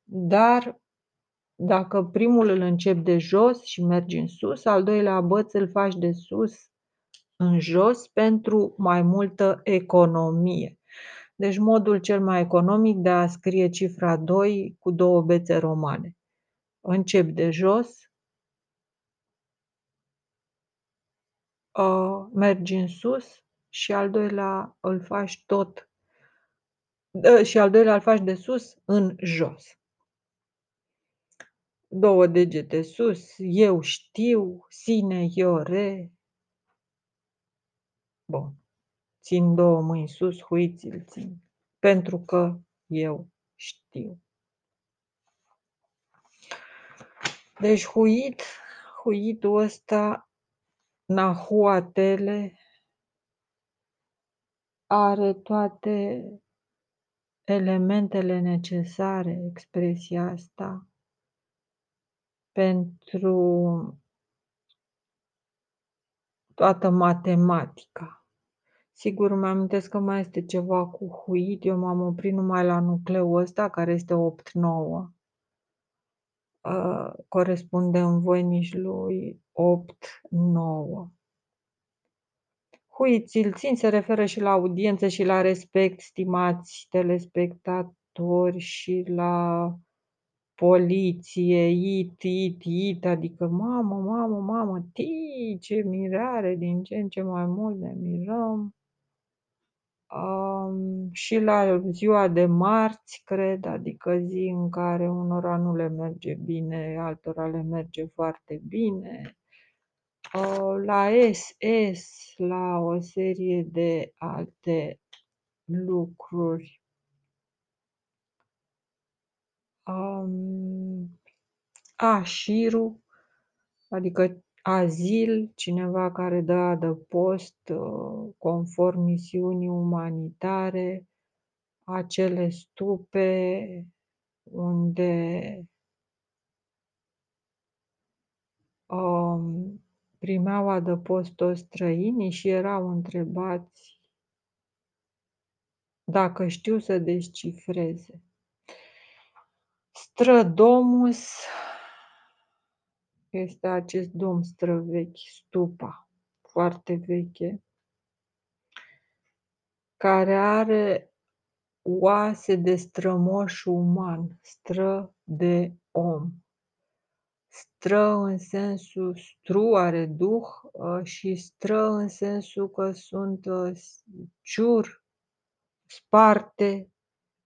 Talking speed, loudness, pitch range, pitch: 80 wpm, -24 LUFS, 175-200 Hz, 185 Hz